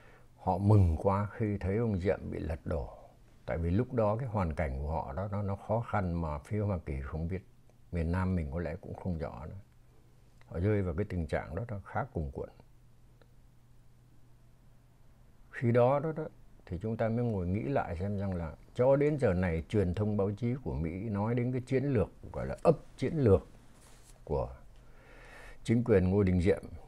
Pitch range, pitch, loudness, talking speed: 90-120 Hz, 105 Hz, -32 LUFS, 200 wpm